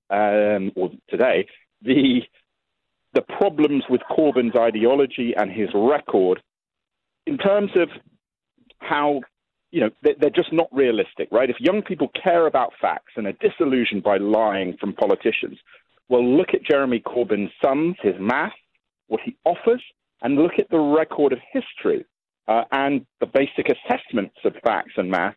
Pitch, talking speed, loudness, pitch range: 140 Hz, 150 wpm, -21 LUFS, 110-175 Hz